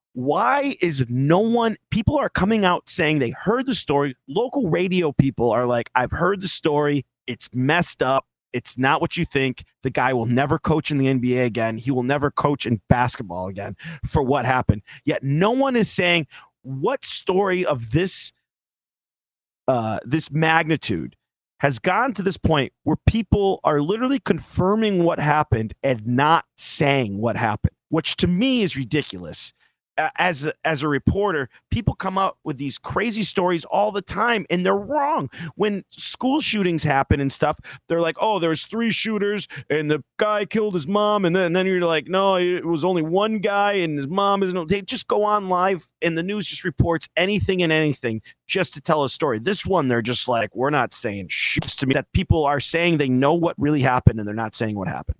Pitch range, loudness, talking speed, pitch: 130-190 Hz, -21 LUFS, 195 wpm, 155 Hz